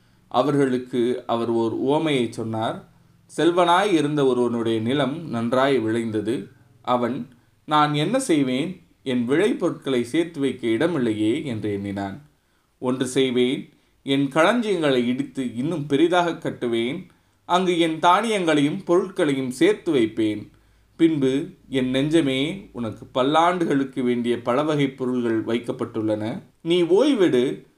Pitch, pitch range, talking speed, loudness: 130 Hz, 115-155 Hz, 105 wpm, -22 LUFS